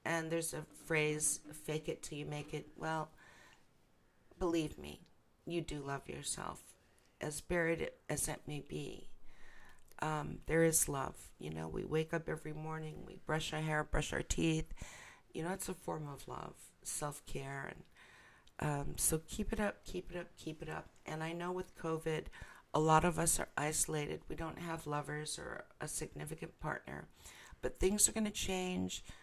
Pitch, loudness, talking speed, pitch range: 155 Hz, -39 LUFS, 175 wpm, 150-165 Hz